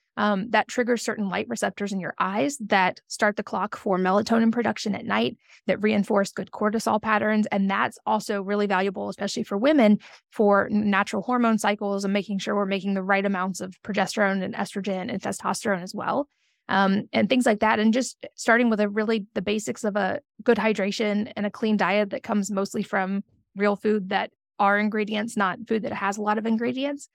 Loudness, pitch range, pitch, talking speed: -24 LUFS, 200-225 Hz, 210 Hz, 195 wpm